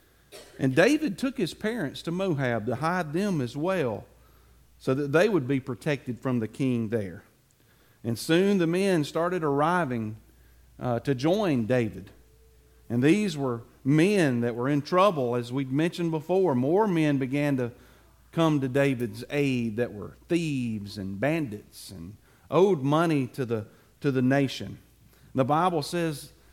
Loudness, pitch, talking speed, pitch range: -26 LUFS, 135 Hz, 155 wpm, 120-165 Hz